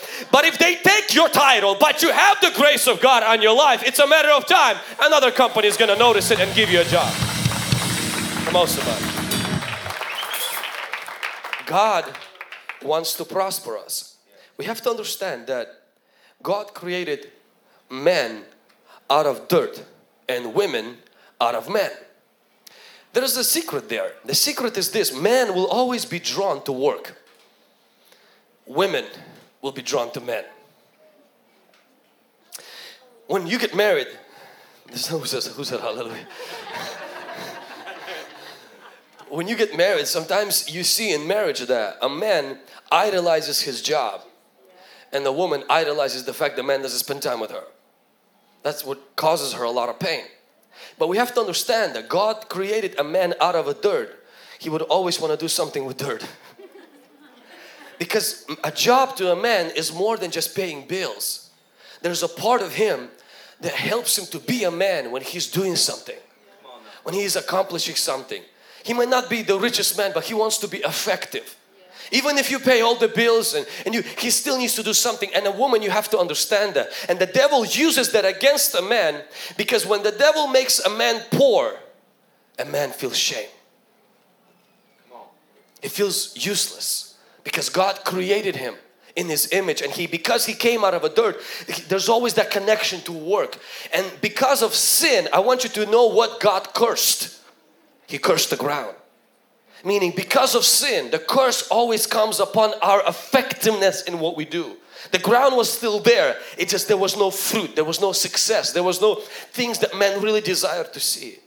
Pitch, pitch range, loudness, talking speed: 220 Hz, 190-265 Hz, -20 LUFS, 170 wpm